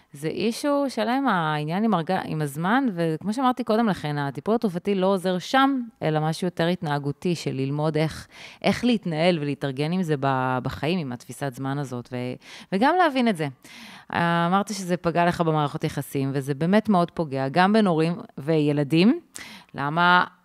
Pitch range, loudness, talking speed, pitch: 145-210 Hz, -24 LUFS, 155 wpm, 170 Hz